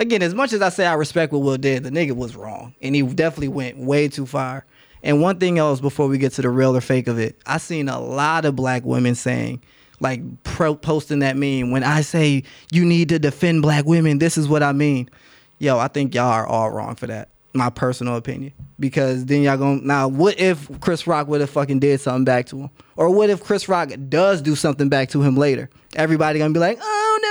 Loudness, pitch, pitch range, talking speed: -19 LUFS, 140 Hz, 130-160 Hz, 240 wpm